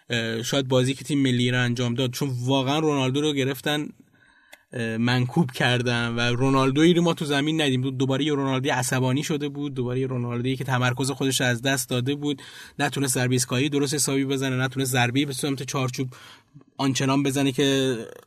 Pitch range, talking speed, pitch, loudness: 125-140 Hz, 165 wpm, 135 Hz, -24 LUFS